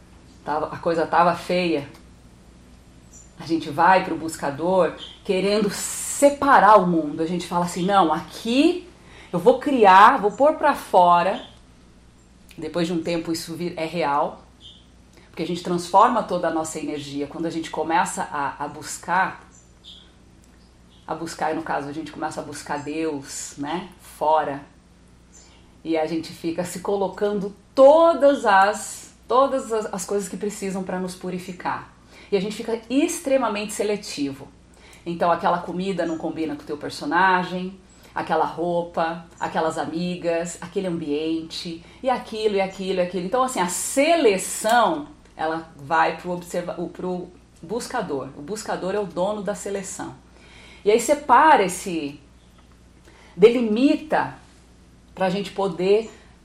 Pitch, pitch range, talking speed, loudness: 175 Hz, 155-200 Hz, 140 wpm, -22 LUFS